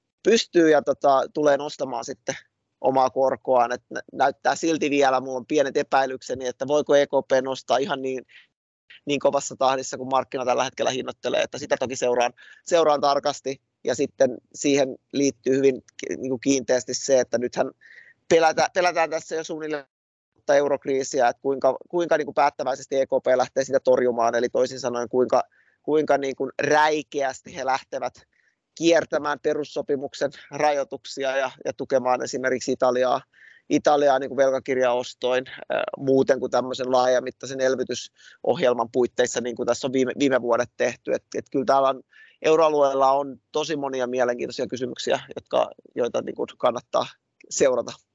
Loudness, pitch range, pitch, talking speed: -23 LUFS, 125-145 Hz, 135 Hz, 140 wpm